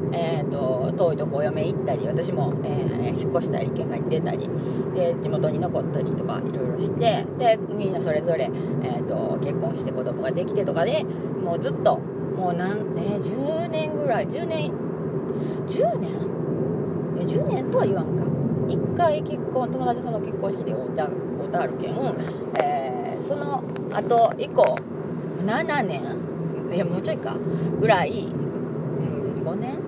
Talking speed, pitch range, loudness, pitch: 260 characters per minute, 190-205 Hz, -25 LUFS, 195 Hz